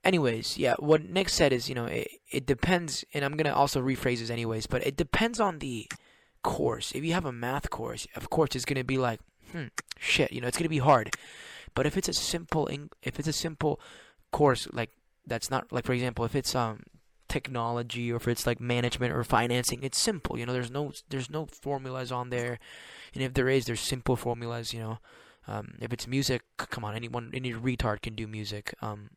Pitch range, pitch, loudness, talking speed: 120-145 Hz, 125 Hz, -30 LUFS, 215 wpm